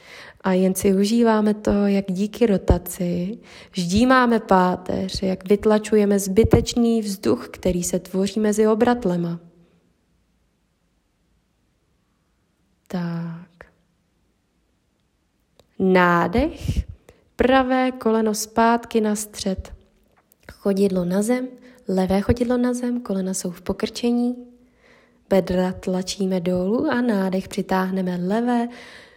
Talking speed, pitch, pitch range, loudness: 95 wpm, 205 Hz, 185-235 Hz, -21 LUFS